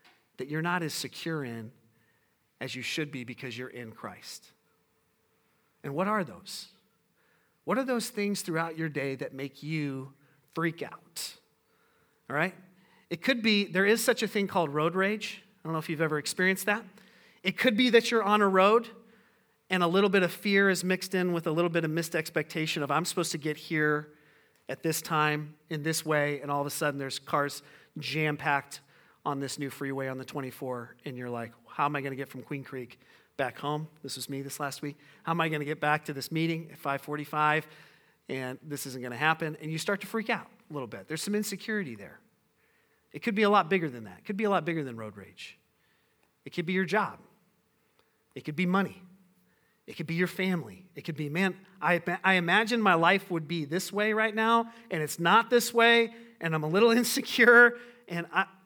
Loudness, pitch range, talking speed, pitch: -29 LUFS, 145-195 Hz, 215 wpm, 165 Hz